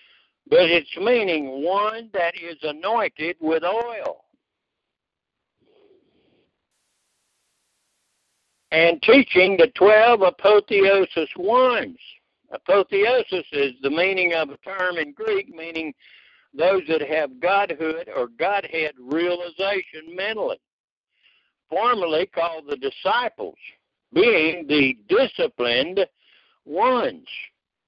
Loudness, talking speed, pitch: -20 LUFS, 90 wpm, 195 Hz